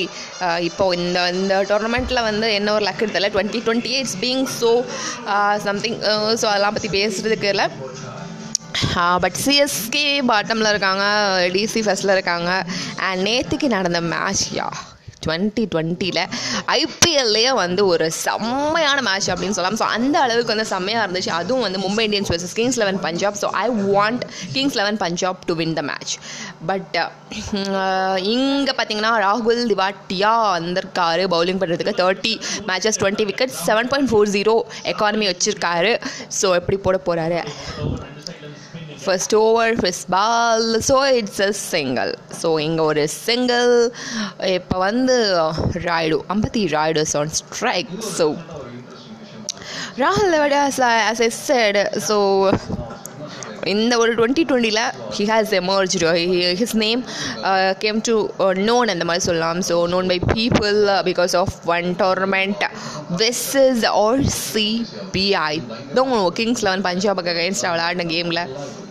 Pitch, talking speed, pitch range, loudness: 200 Hz, 125 wpm, 180-225 Hz, -19 LUFS